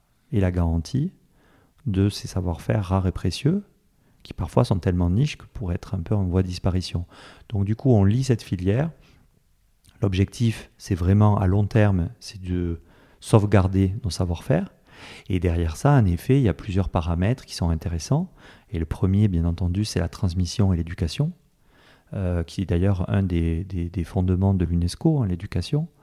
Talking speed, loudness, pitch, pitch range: 180 wpm, -24 LUFS, 100 Hz, 90-115 Hz